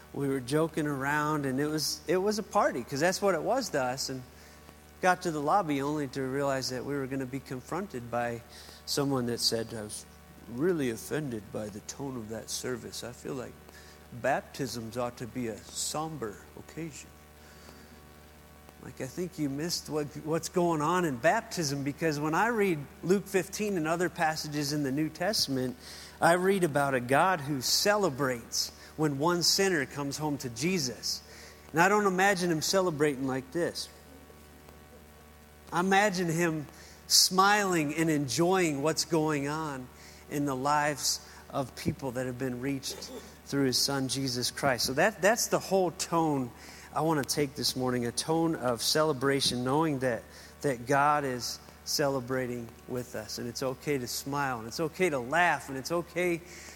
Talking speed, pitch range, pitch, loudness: 170 wpm, 115-160 Hz, 140 Hz, -30 LUFS